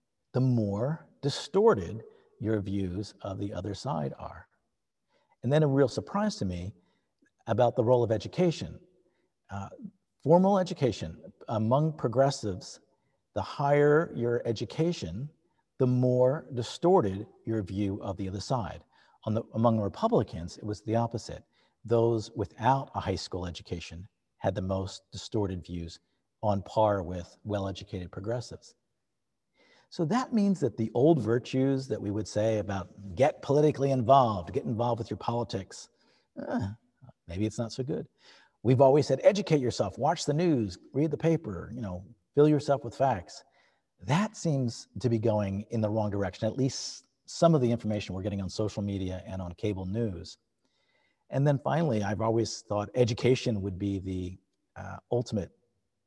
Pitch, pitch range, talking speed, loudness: 115 Hz, 100-135 Hz, 155 wpm, -29 LUFS